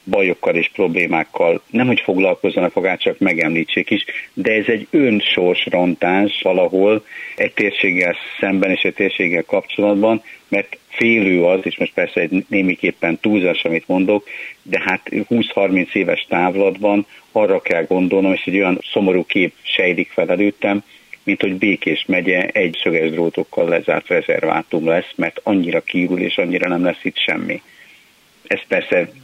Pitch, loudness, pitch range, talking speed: 100 Hz, -17 LUFS, 90-110 Hz, 145 wpm